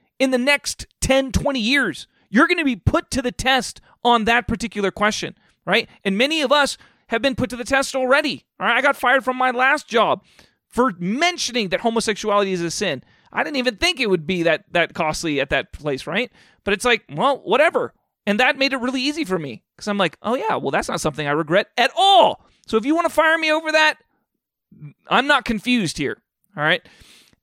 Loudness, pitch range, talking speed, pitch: -19 LUFS, 195-270 Hz, 220 wpm, 240 Hz